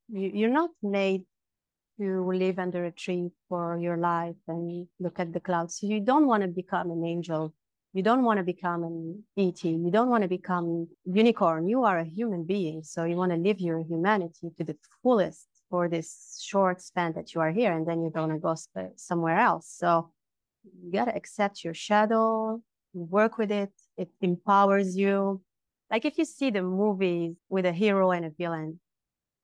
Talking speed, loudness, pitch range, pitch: 185 wpm, -28 LUFS, 170-200 Hz, 180 Hz